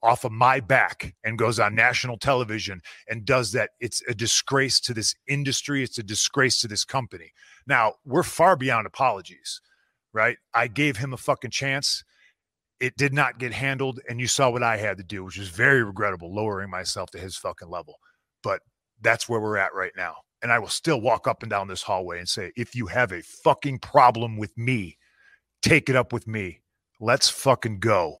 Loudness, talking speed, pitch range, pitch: -24 LUFS, 200 wpm, 105-130 Hz, 120 Hz